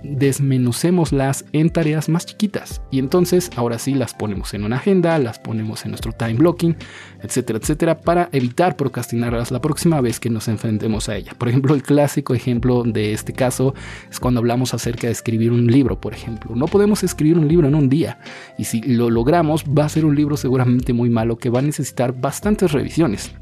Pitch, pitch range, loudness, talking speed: 130 Hz, 115-155 Hz, -18 LUFS, 200 wpm